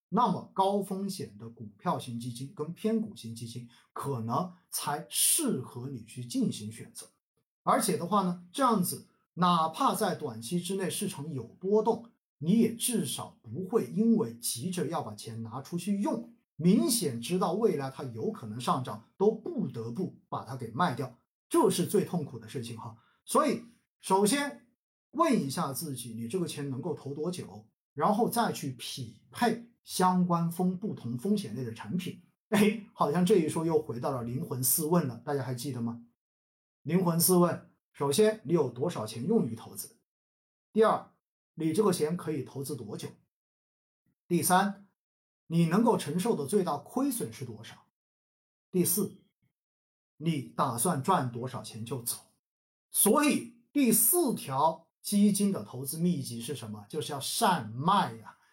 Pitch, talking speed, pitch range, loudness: 170 Hz, 230 characters per minute, 125-205 Hz, -30 LUFS